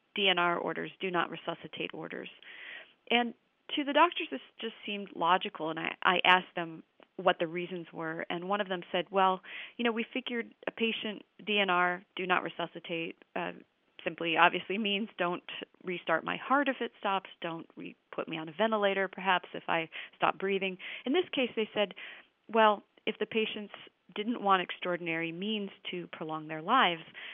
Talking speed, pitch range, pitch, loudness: 175 wpm, 175-220 Hz, 190 Hz, -32 LUFS